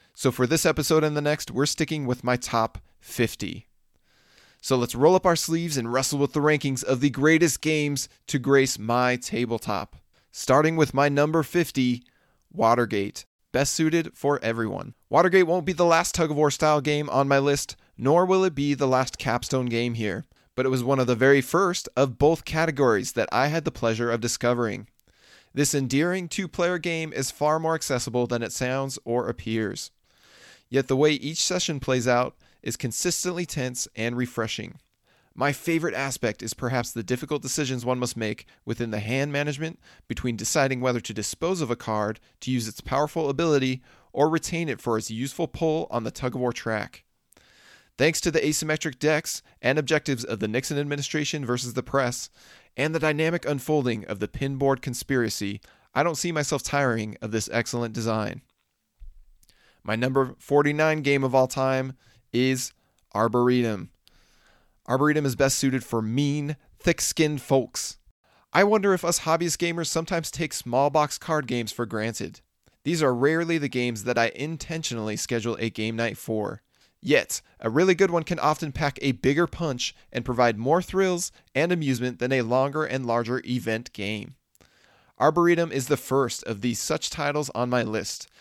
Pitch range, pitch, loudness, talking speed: 120-155 Hz, 135 Hz, -25 LUFS, 175 wpm